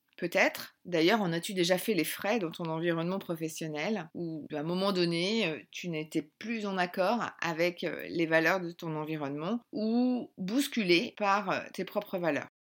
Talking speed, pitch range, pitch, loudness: 160 wpm, 160-205 Hz, 175 Hz, -31 LUFS